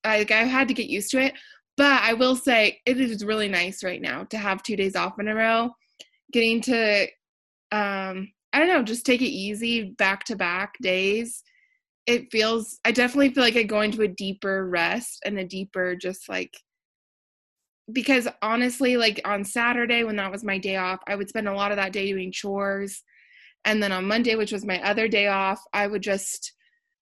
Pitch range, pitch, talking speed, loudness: 195-240 Hz, 215 Hz, 200 wpm, -23 LUFS